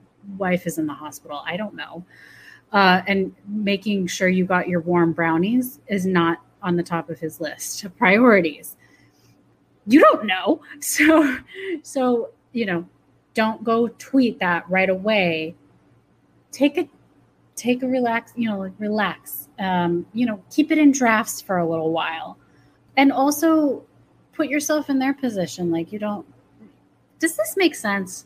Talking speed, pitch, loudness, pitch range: 155 wpm, 205 Hz, -21 LUFS, 175-260 Hz